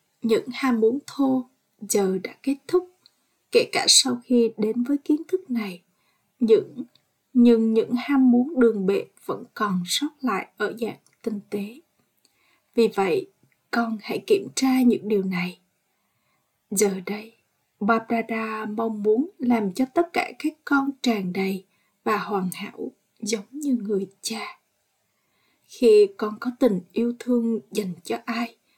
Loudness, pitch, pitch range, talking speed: -23 LUFS, 230 Hz, 210-265 Hz, 150 wpm